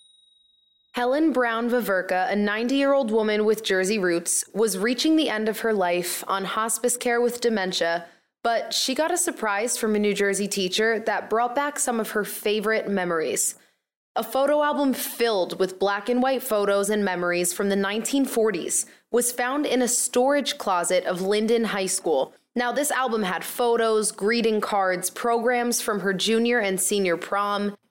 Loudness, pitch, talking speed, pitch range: -23 LUFS, 220 Hz, 170 wpm, 200-245 Hz